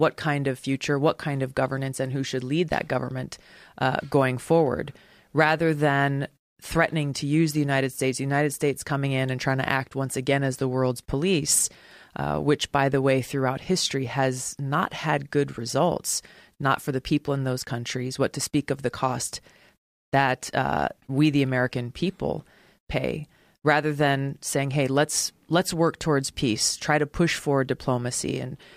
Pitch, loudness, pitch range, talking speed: 140 Hz, -25 LUFS, 130-150 Hz, 180 wpm